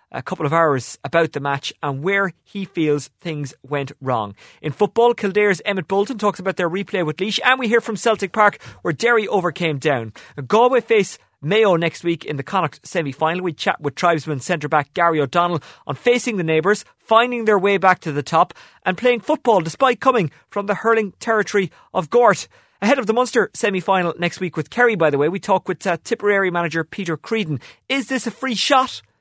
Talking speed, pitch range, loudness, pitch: 200 wpm, 155-220 Hz, -19 LUFS, 185 Hz